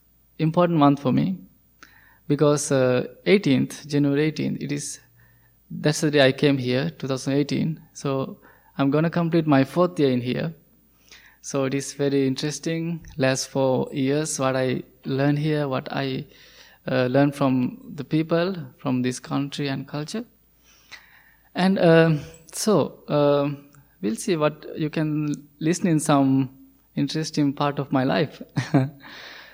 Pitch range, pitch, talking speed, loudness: 135-160 Hz, 145 Hz, 140 wpm, -23 LUFS